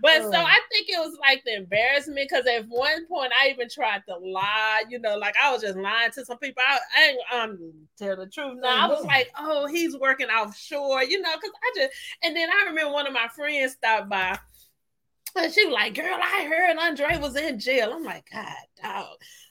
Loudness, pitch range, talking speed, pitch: -23 LUFS, 230-330 Hz, 225 wpm, 275 Hz